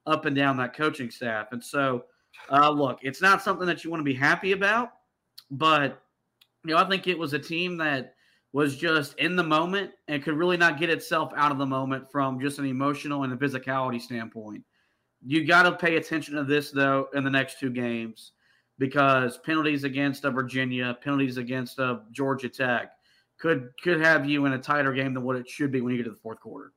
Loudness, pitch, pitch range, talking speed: -25 LUFS, 140 Hz, 130-155 Hz, 215 wpm